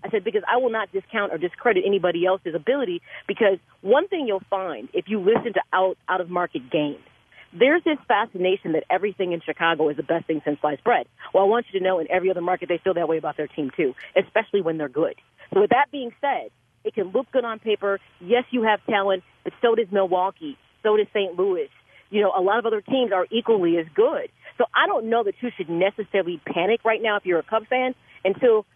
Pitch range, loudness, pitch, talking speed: 180-230 Hz, -23 LUFS, 200 Hz, 235 wpm